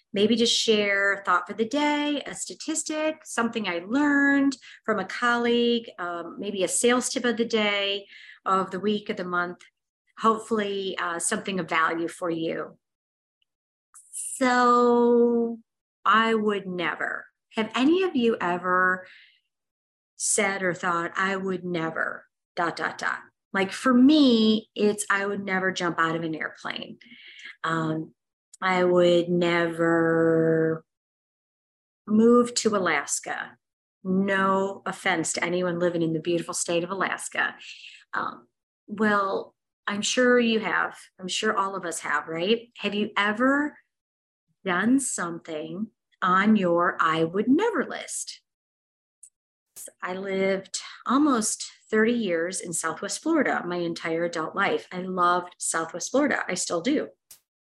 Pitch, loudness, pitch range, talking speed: 195 Hz, -25 LUFS, 175-230 Hz, 135 wpm